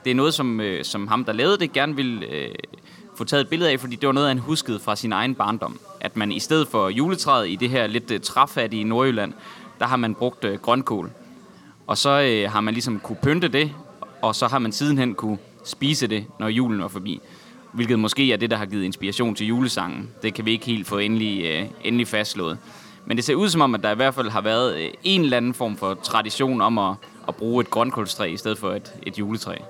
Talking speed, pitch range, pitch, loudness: 230 wpm, 105-130 Hz, 115 Hz, -22 LUFS